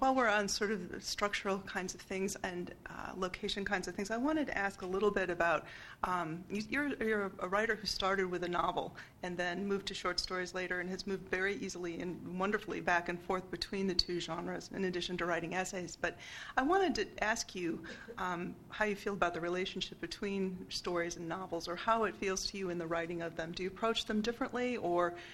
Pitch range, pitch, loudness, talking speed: 175-205 Hz, 190 Hz, -36 LUFS, 225 wpm